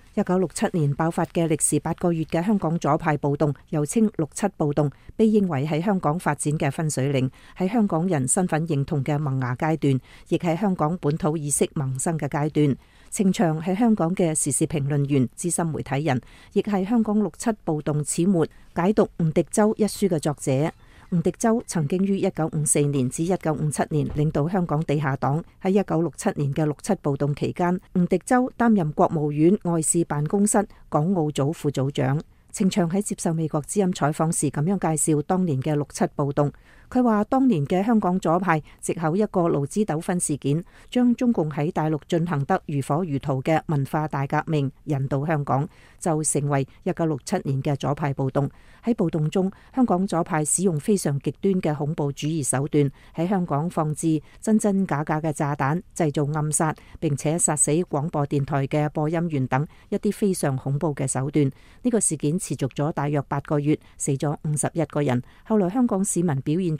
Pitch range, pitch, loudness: 145-185 Hz, 160 Hz, -24 LUFS